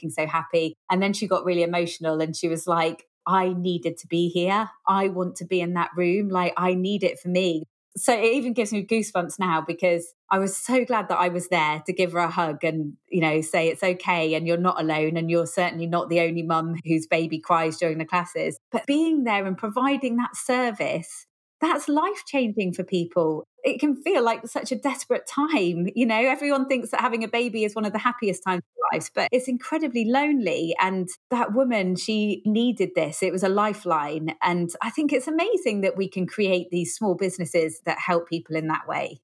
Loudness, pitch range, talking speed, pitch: -24 LUFS, 170-230 Hz, 215 wpm, 185 Hz